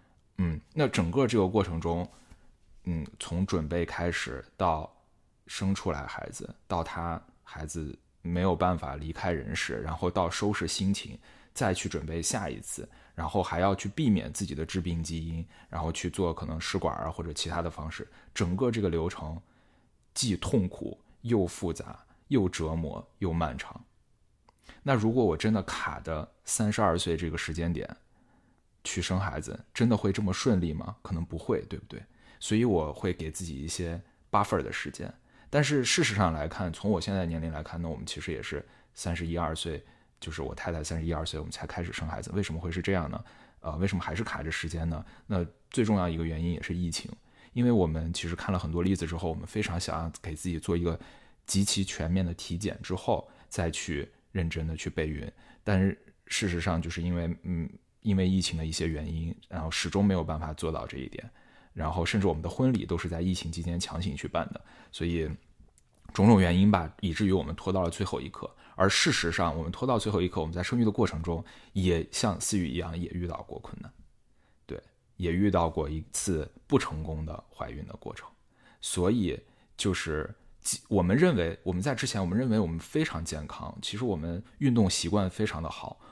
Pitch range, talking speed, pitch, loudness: 80-100 Hz, 295 characters per minute, 85 Hz, -31 LUFS